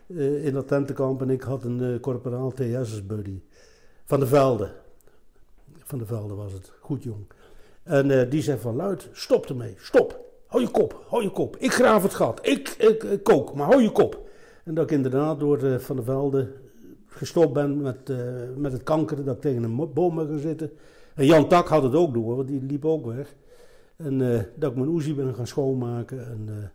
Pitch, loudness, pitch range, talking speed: 140 Hz, -24 LUFS, 125-155 Hz, 220 wpm